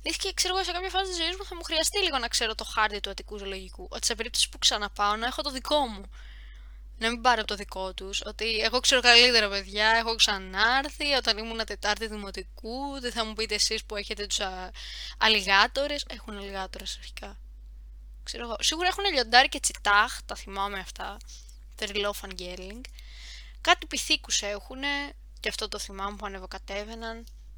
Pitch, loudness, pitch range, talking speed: 220 Hz, -26 LUFS, 200-260 Hz, 180 wpm